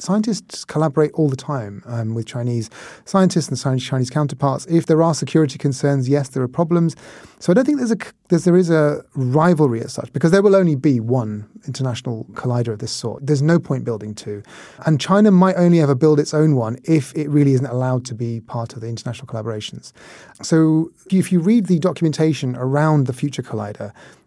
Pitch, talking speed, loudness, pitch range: 145 Hz, 200 wpm, -18 LUFS, 120-165 Hz